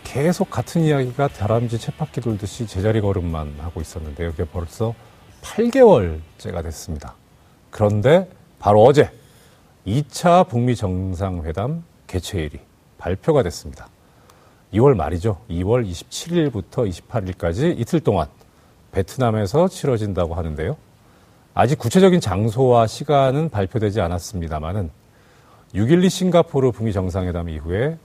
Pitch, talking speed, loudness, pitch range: 110 Hz, 280 characters per minute, -20 LUFS, 90-135 Hz